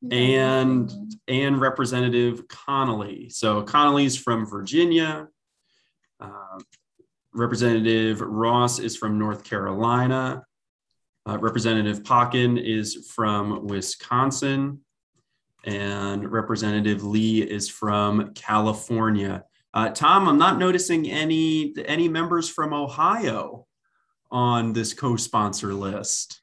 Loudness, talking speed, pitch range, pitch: -23 LUFS, 95 wpm, 105-130 Hz, 115 Hz